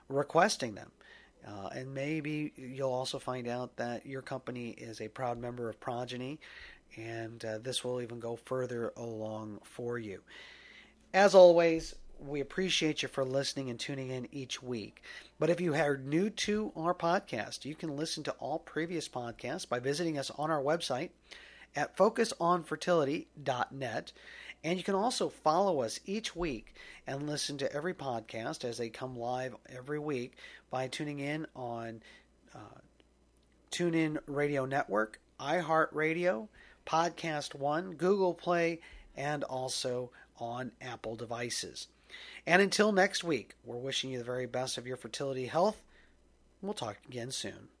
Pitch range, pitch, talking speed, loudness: 120-165 Hz, 135 Hz, 150 wpm, -34 LUFS